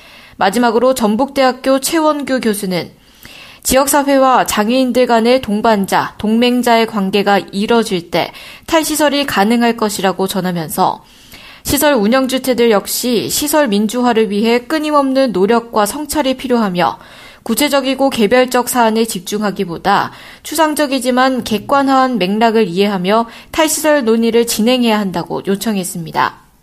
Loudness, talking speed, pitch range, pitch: -14 LUFS, 315 characters per minute, 205-265 Hz, 235 Hz